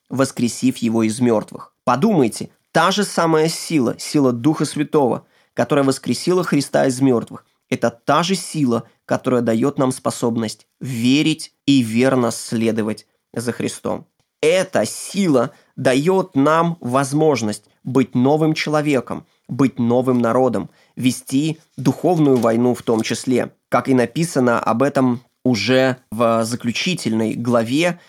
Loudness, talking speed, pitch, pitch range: -18 LUFS, 120 wpm, 130 Hz, 120-150 Hz